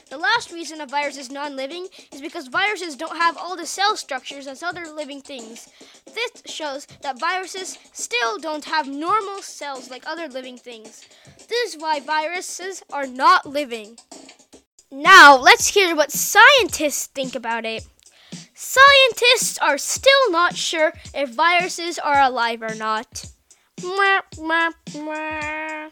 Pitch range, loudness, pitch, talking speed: 280-360 Hz, -17 LUFS, 310 Hz, 140 wpm